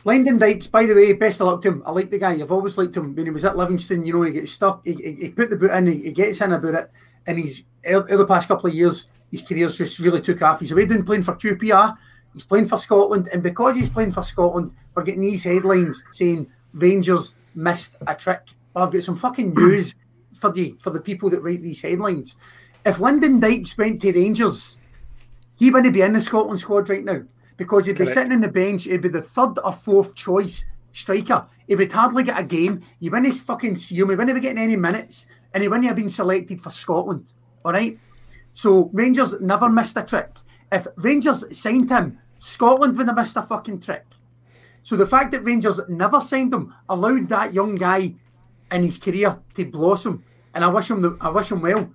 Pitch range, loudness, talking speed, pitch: 170-210 Hz, -19 LUFS, 225 wpm, 190 Hz